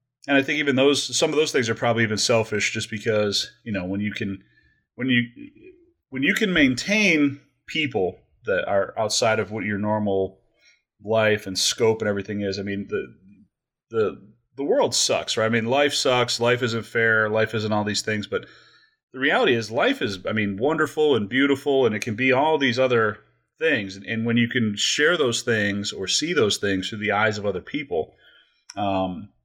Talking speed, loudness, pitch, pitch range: 200 wpm, -22 LUFS, 110 Hz, 105-130 Hz